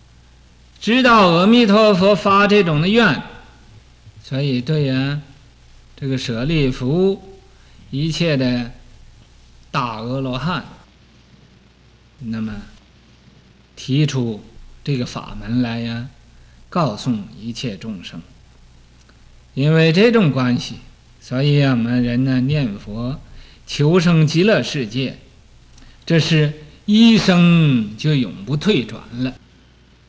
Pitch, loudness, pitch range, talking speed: 130 Hz, -17 LUFS, 115-160 Hz, 150 characters per minute